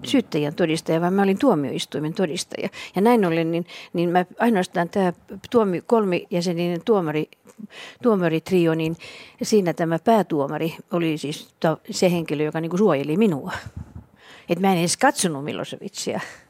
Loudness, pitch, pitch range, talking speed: -22 LUFS, 175 Hz, 160-210 Hz, 140 wpm